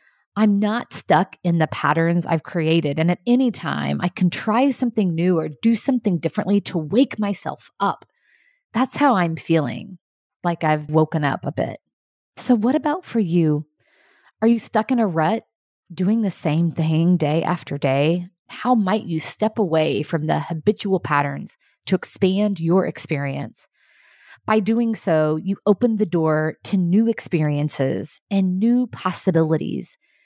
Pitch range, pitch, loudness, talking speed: 160-220 Hz, 180 Hz, -21 LUFS, 155 wpm